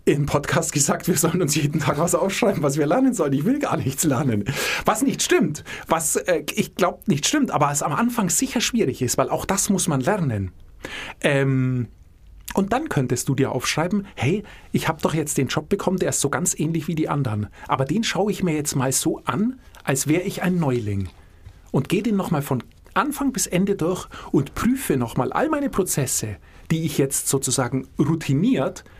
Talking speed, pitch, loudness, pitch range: 205 wpm, 155 Hz, -22 LUFS, 135-185 Hz